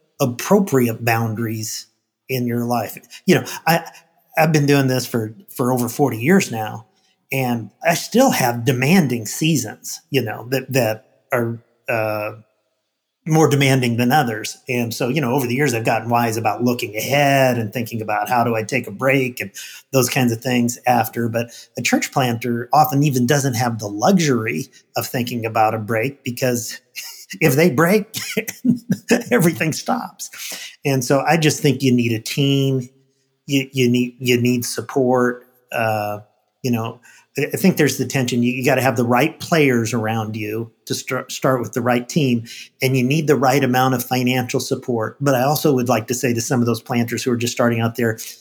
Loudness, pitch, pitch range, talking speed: -19 LUFS, 125 Hz, 115-140 Hz, 185 wpm